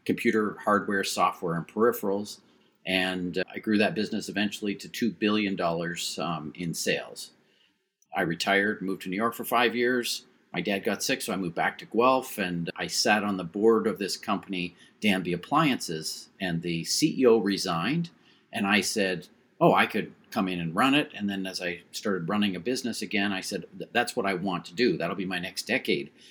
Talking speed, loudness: 195 wpm, -27 LUFS